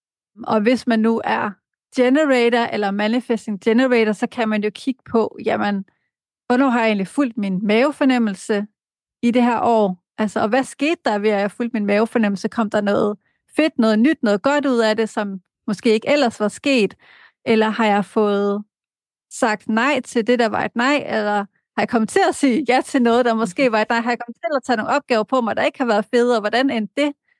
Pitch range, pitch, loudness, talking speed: 215-255 Hz, 230 Hz, -19 LUFS, 220 wpm